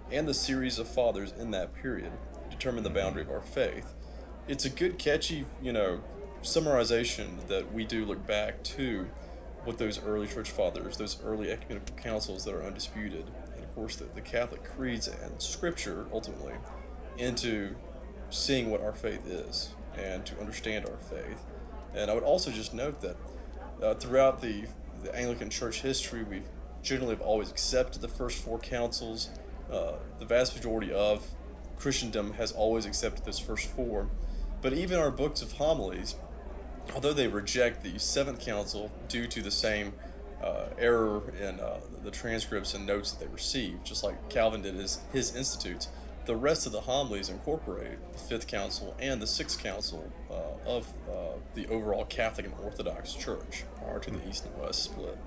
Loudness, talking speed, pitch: -33 LUFS, 170 wpm, 105 Hz